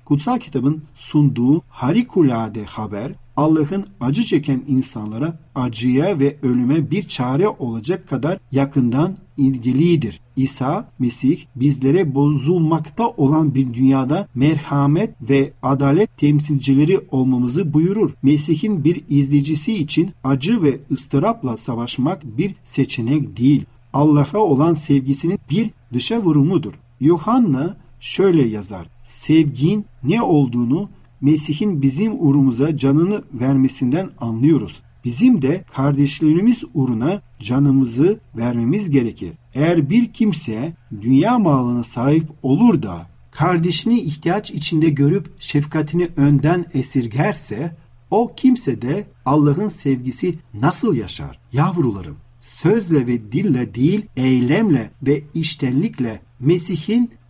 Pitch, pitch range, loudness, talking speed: 145 Hz, 130-165 Hz, -18 LUFS, 105 wpm